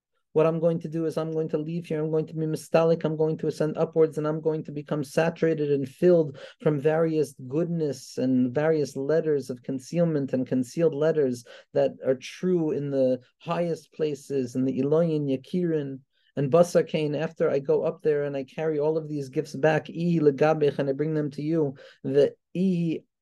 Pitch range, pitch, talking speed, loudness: 140-165 Hz, 155 Hz, 195 wpm, -26 LUFS